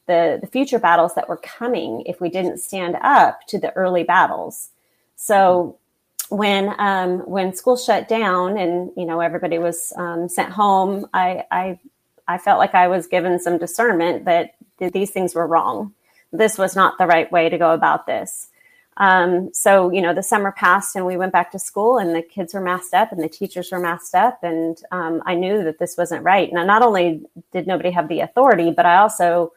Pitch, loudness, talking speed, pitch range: 180 Hz, -18 LUFS, 205 wpm, 170-195 Hz